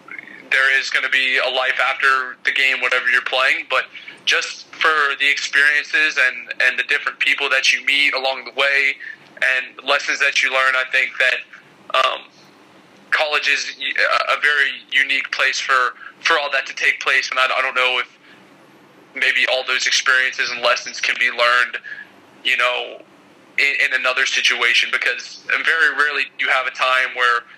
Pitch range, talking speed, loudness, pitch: 125-130 Hz, 175 wpm, -16 LUFS, 130 Hz